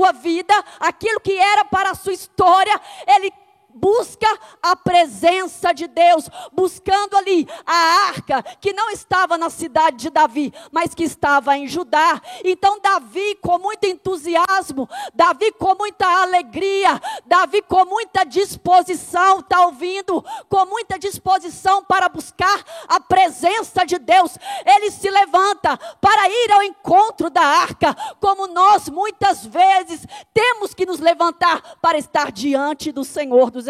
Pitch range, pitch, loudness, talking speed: 335-395 Hz, 370 Hz, -17 LUFS, 140 wpm